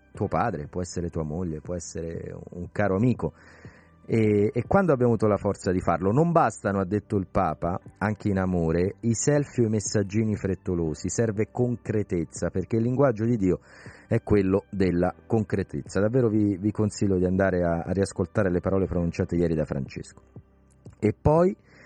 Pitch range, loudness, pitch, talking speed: 90-110 Hz, -26 LUFS, 100 Hz, 175 wpm